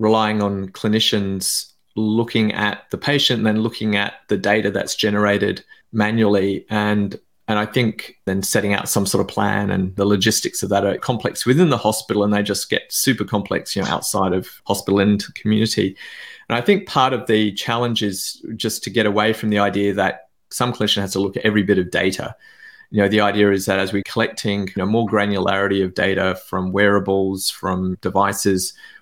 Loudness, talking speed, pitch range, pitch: -19 LUFS, 195 wpm, 100-110 Hz, 105 Hz